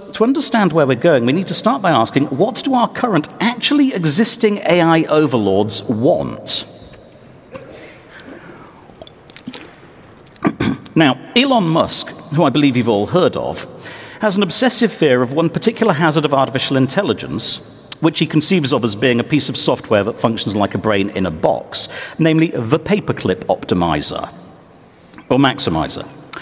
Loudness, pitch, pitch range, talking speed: -15 LUFS, 160 Hz, 130-210 Hz, 150 wpm